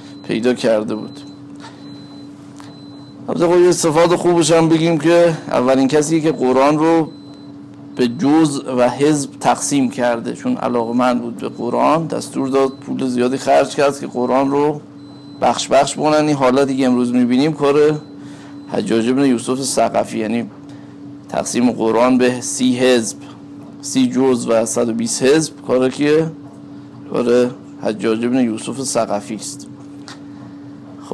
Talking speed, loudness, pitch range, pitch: 135 wpm, -16 LUFS, 125-145 Hz, 135 Hz